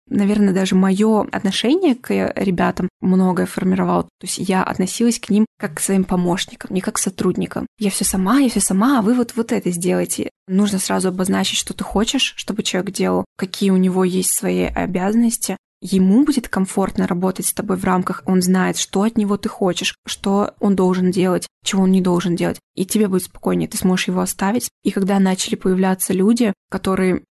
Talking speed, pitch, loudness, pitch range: 190 wpm, 195 Hz, -18 LUFS, 185-210 Hz